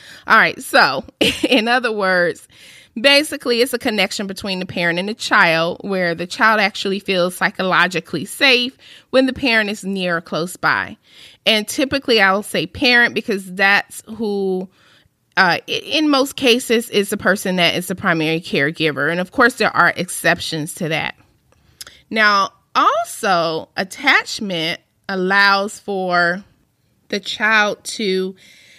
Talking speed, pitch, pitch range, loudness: 140 wpm, 195 Hz, 180-230 Hz, -16 LUFS